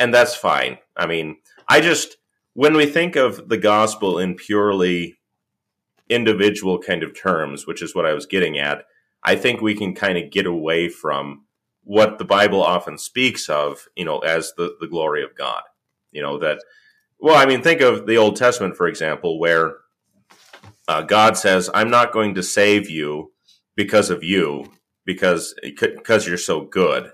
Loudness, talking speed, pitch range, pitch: -18 LUFS, 180 wpm, 85-125 Hz, 105 Hz